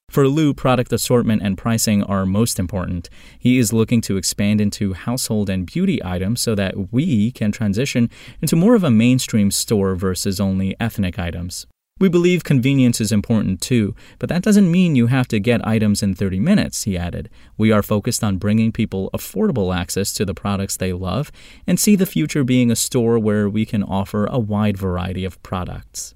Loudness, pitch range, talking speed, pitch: -18 LUFS, 95-125 Hz, 190 wpm, 110 Hz